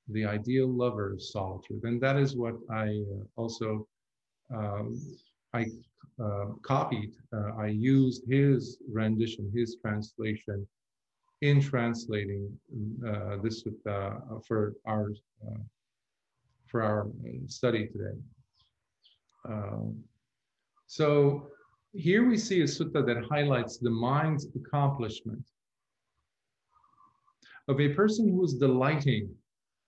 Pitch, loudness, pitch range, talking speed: 115 Hz, -30 LUFS, 105-135 Hz, 100 wpm